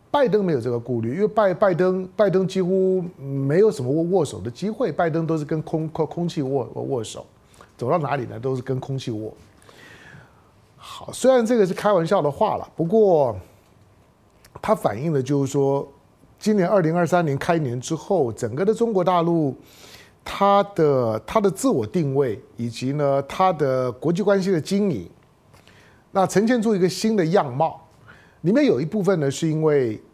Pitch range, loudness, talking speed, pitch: 135-190 Hz, -21 LUFS, 255 characters per minute, 160 Hz